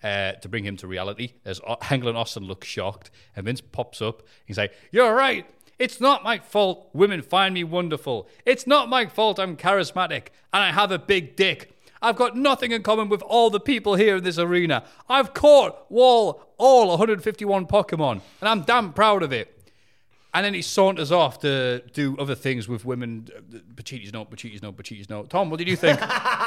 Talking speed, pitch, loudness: 195 wpm, 180 Hz, -21 LUFS